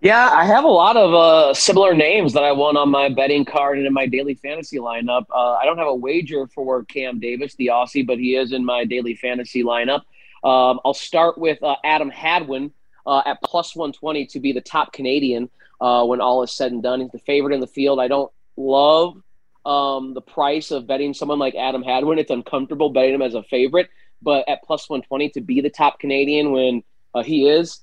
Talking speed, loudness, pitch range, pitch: 220 wpm, -18 LUFS, 125-145 Hz, 135 Hz